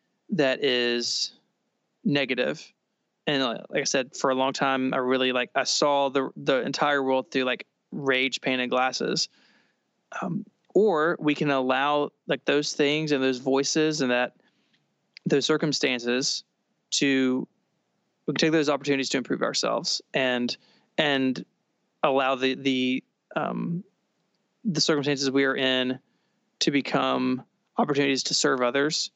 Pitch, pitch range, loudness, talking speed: 135 Hz, 130-150 Hz, -25 LUFS, 140 wpm